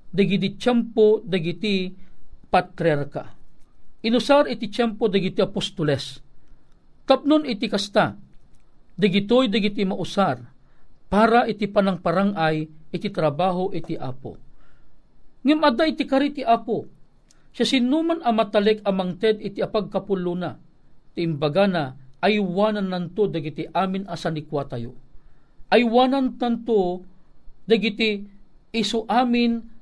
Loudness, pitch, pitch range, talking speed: -22 LUFS, 200 Hz, 170-230 Hz, 95 wpm